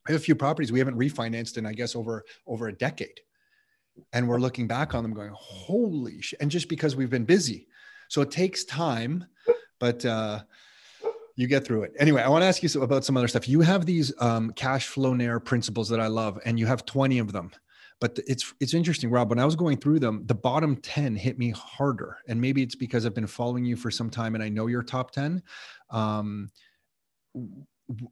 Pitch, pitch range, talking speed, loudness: 130 Hz, 115-150 Hz, 220 wpm, -27 LUFS